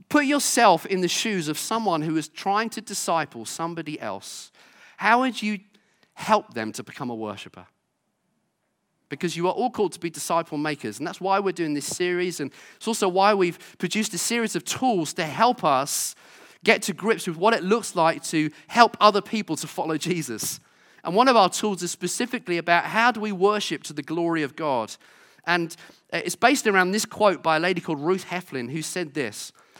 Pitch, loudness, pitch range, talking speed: 180 Hz, -24 LUFS, 160-210 Hz, 200 wpm